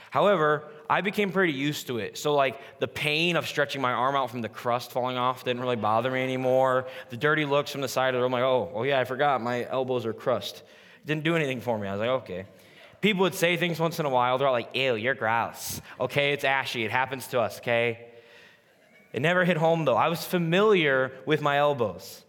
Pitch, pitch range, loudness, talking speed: 135 Hz, 125-155 Hz, -26 LUFS, 235 wpm